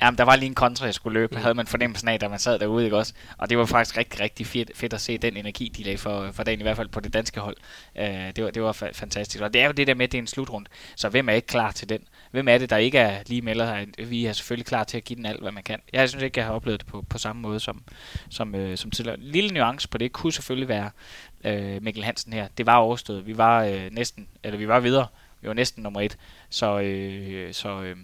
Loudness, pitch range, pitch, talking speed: -25 LUFS, 105-120 Hz, 110 Hz, 290 wpm